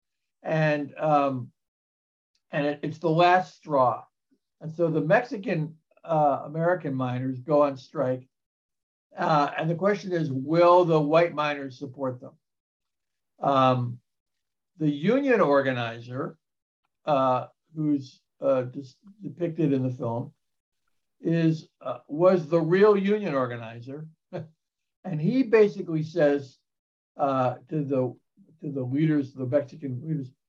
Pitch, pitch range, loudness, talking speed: 150 Hz, 130-165 Hz, -25 LUFS, 120 wpm